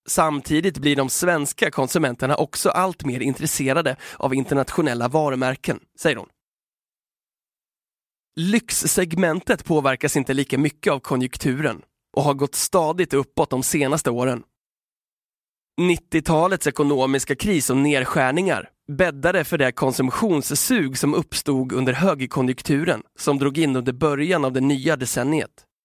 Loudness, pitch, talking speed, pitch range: -21 LUFS, 145 Hz, 120 wpm, 135-165 Hz